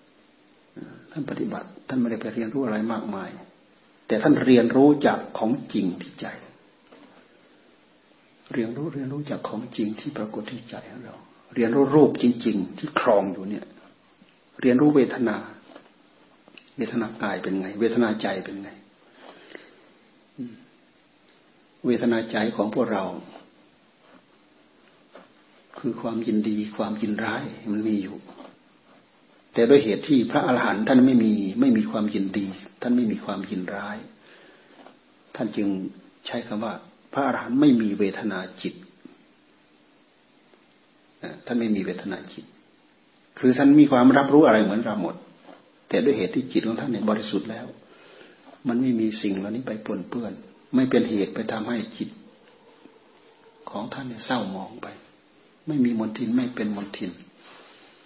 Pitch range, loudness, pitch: 105-135 Hz, -24 LUFS, 115 Hz